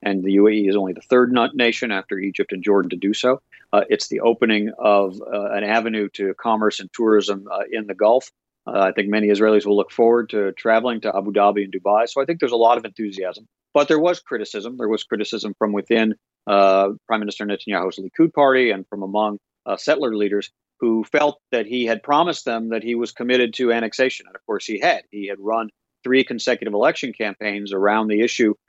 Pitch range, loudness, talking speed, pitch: 100-120 Hz, -20 LUFS, 215 wpm, 110 Hz